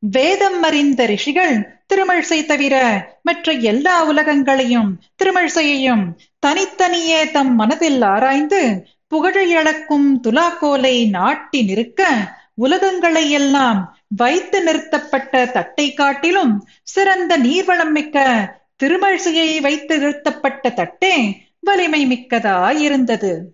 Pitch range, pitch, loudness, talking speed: 250-335 Hz, 290 Hz, -15 LUFS, 80 wpm